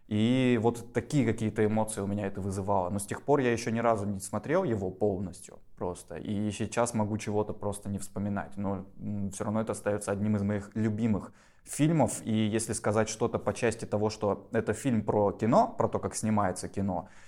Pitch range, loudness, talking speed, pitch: 100-115 Hz, -30 LUFS, 195 wpm, 105 Hz